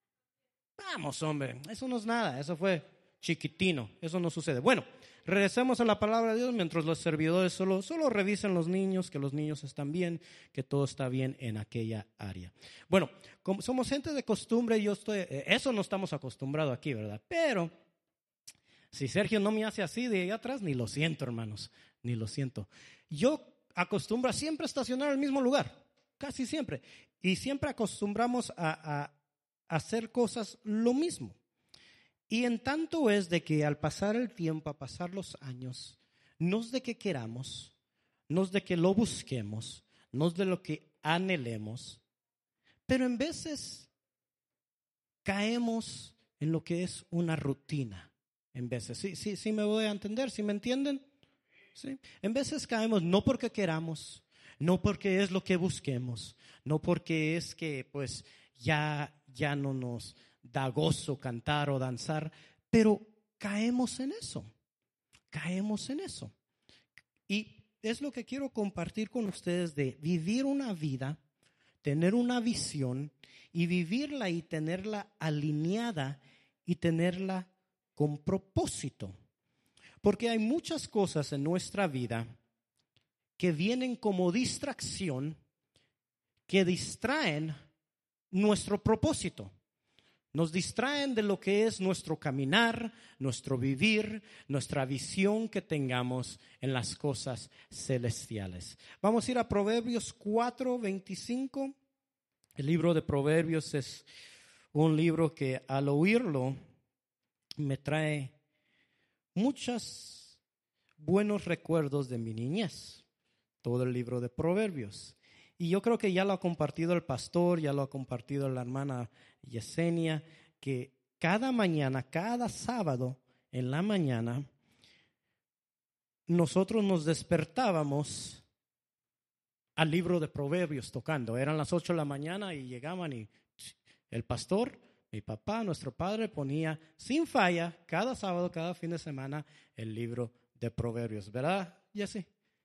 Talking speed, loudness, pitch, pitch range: 140 wpm, -33 LUFS, 165 Hz, 135-210 Hz